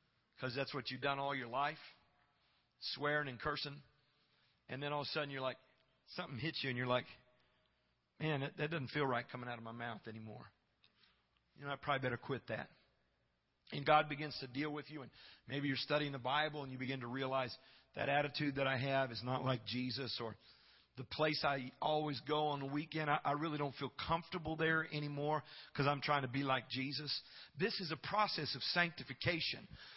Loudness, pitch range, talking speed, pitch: -40 LUFS, 130-150 Hz, 200 wpm, 140 Hz